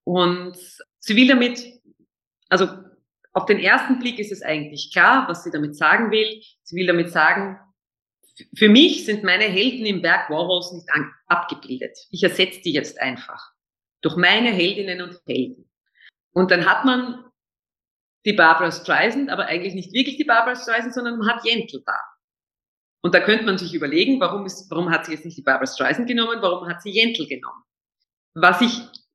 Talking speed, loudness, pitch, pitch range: 175 wpm, -19 LUFS, 190 Hz, 175-235 Hz